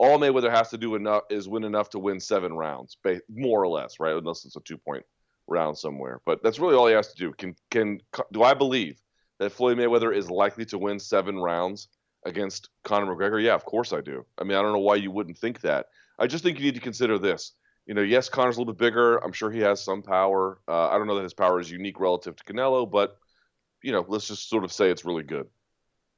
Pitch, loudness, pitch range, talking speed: 100 Hz, -25 LUFS, 95-115 Hz, 250 wpm